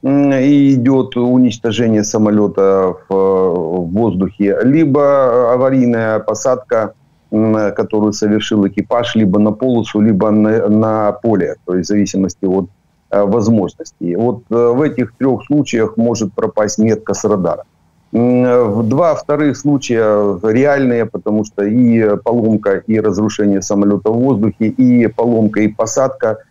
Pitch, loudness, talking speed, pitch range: 110 Hz, -13 LUFS, 120 wpm, 105-120 Hz